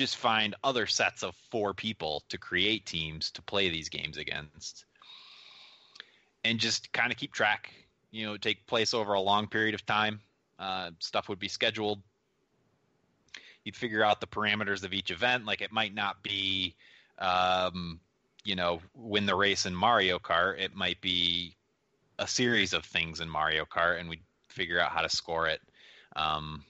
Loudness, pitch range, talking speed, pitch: -30 LUFS, 85-105 Hz, 175 wpm, 100 Hz